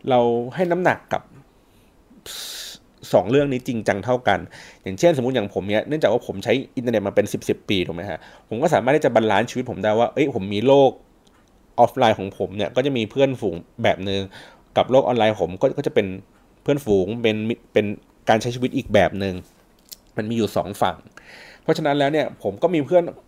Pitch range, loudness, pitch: 105-135 Hz, -21 LUFS, 120 Hz